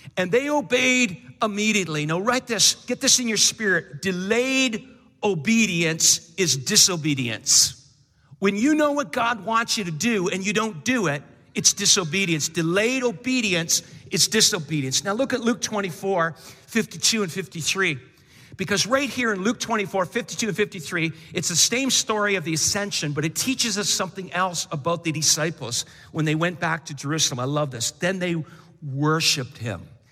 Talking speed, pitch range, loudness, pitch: 165 wpm, 160-225 Hz, -21 LUFS, 185 Hz